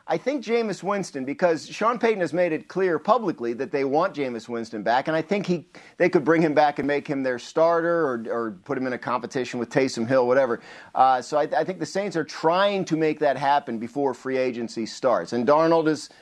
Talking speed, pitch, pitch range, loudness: 235 wpm, 150 Hz, 130-170 Hz, -24 LUFS